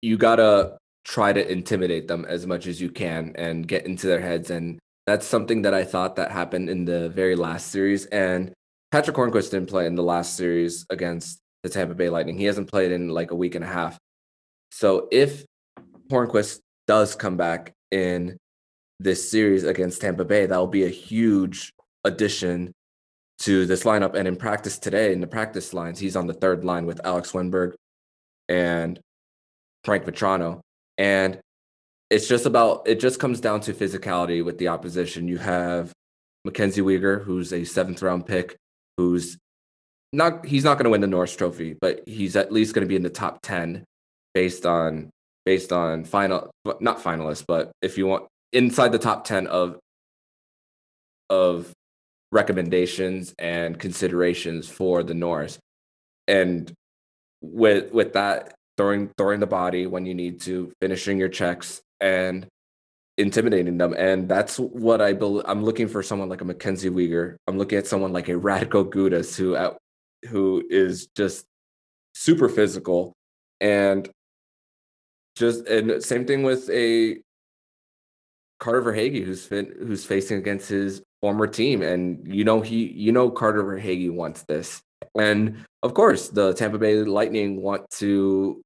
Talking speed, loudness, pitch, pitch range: 165 wpm, -23 LUFS, 90 Hz, 85-100 Hz